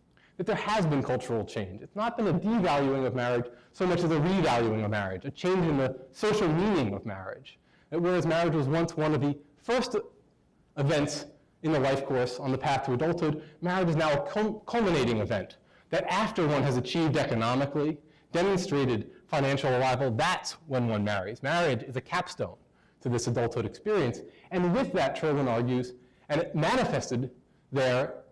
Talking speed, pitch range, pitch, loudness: 180 wpm, 125-175 Hz, 145 Hz, -29 LUFS